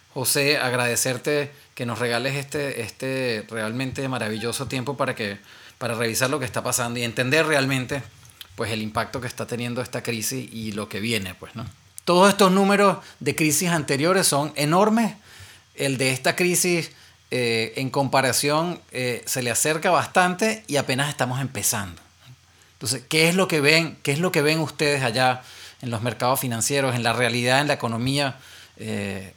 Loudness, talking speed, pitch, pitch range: -22 LUFS, 170 wpm, 130 Hz, 115-145 Hz